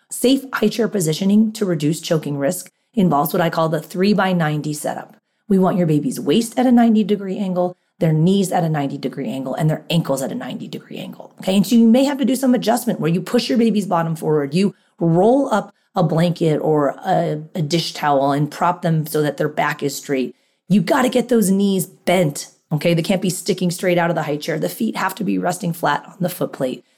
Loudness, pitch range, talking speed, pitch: -18 LUFS, 155-210 Hz, 240 wpm, 180 Hz